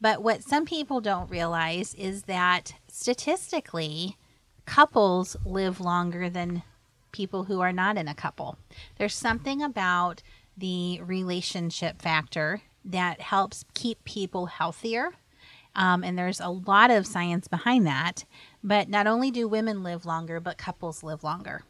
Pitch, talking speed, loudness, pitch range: 185 Hz, 140 wpm, -27 LUFS, 175-210 Hz